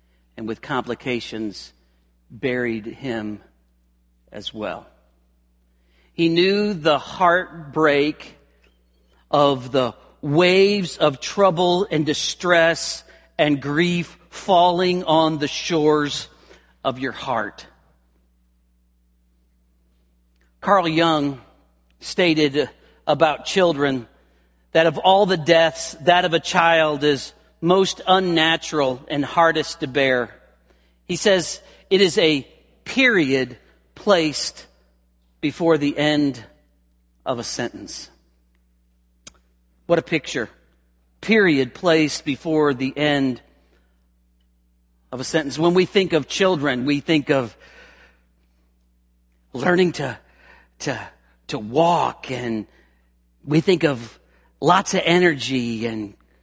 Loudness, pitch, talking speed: -20 LUFS, 130 Hz, 100 wpm